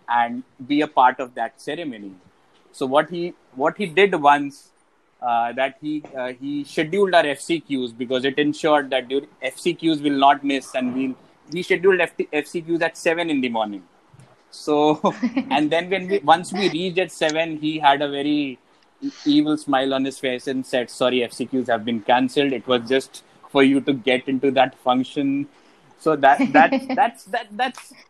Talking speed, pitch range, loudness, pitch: 180 wpm, 130-170 Hz, -21 LUFS, 145 Hz